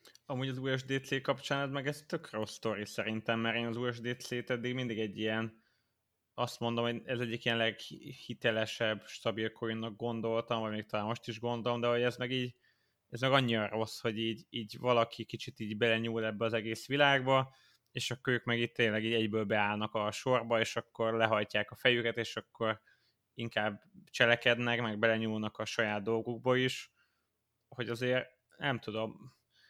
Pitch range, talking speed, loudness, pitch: 110-125 Hz, 170 wpm, -34 LUFS, 115 Hz